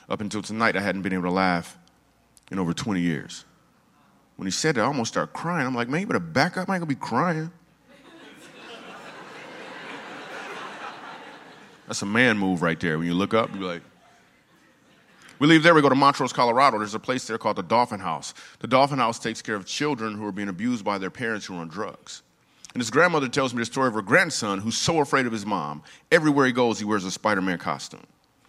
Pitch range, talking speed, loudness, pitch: 95-140 Hz, 220 wpm, -24 LUFS, 110 Hz